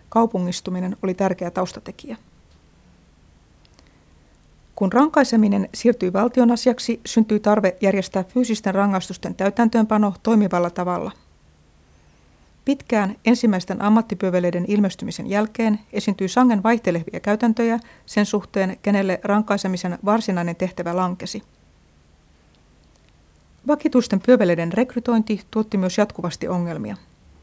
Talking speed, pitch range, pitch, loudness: 90 wpm, 180-225 Hz, 200 Hz, -20 LUFS